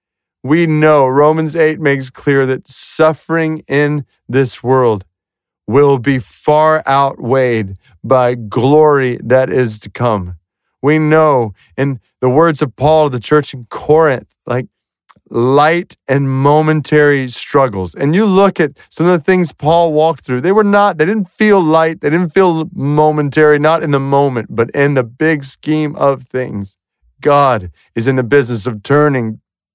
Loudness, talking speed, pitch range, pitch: -12 LUFS, 155 wpm, 125-155 Hz, 140 Hz